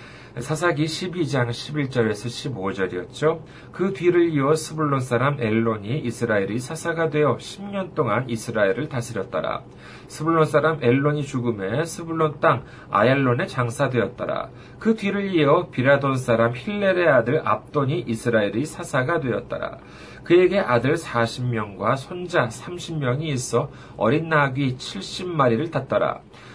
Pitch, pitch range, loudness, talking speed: 140 Hz, 120-160 Hz, -22 LUFS, 280 characters per minute